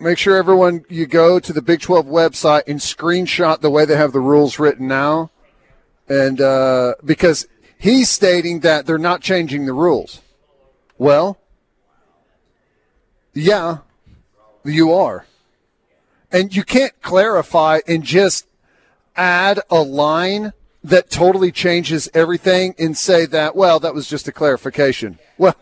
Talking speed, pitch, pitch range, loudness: 135 wpm, 165 Hz, 145-180 Hz, -15 LUFS